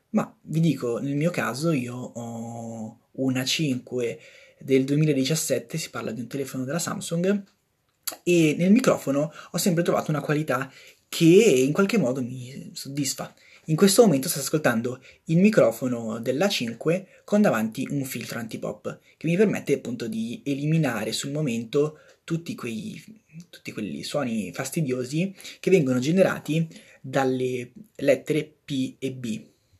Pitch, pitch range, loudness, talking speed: 145 Hz, 130-175 Hz, -25 LUFS, 135 wpm